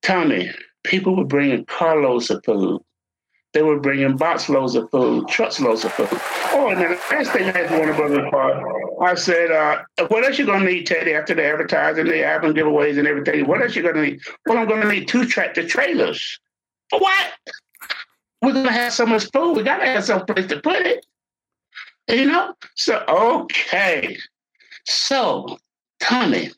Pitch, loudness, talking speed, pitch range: 185 Hz, -19 LUFS, 175 wpm, 155-245 Hz